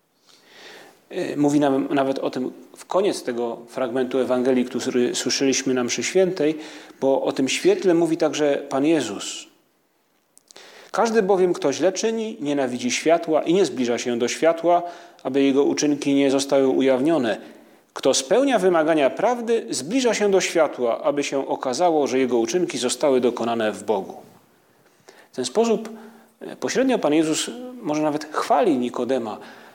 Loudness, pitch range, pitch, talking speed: -21 LUFS, 130-175 Hz, 145 Hz, 140 wpm